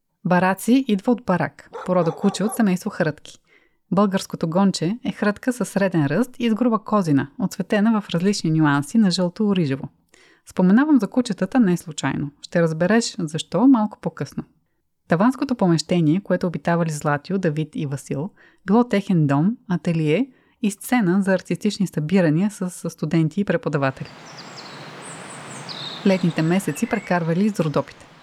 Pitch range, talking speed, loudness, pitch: 165-210 Hz, 130 wpm, -21 LUFS, 185 Hz